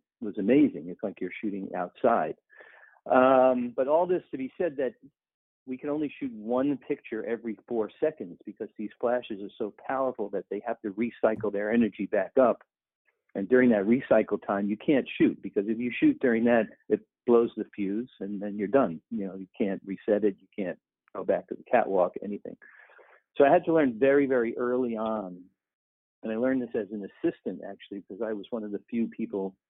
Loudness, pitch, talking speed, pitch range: -28 LUFS, 115 Hz, 200 wpm, 100-130 Hz